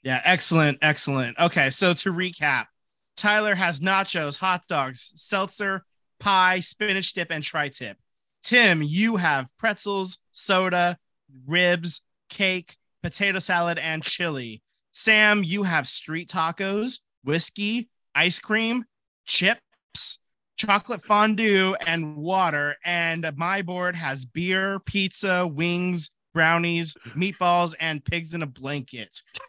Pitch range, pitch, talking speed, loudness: 155-195 Hz, 175 Hz, 115 wpm, -23 LUFS